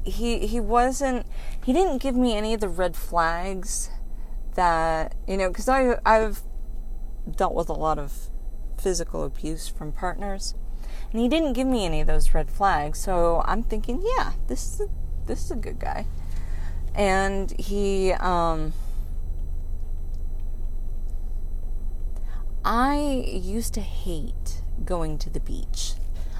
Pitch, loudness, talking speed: 160 Hz, -27 LUFS, 135 wpm